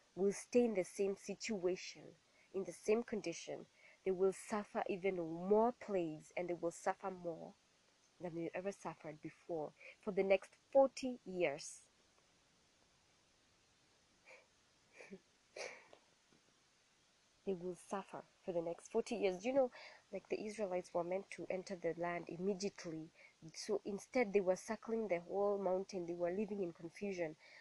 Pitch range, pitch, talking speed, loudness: 175-210 Hz, 190 Hz, 140 wpm, -41 LUFS